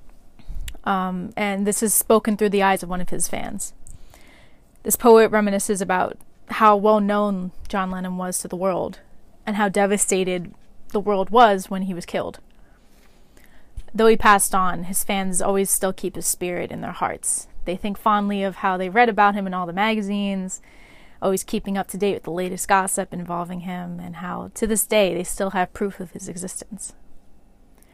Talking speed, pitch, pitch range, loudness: 185 wpm, 195 Hz, 185-210 Hz, -21 LUFS